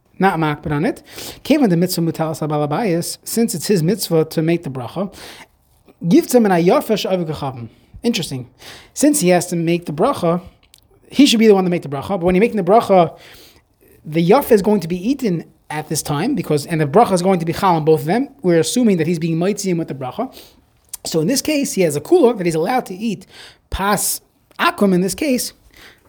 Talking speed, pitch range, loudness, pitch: 215 wpm, 160-220 Hz, -17 LUFS, 180 Hz